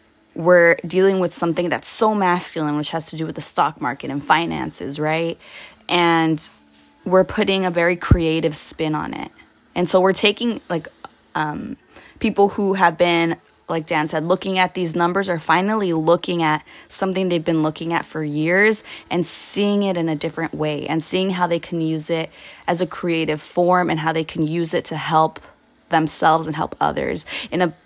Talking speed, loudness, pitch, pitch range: 185 wpm, -19 LUFS, 170 Hz, 160-180 Hz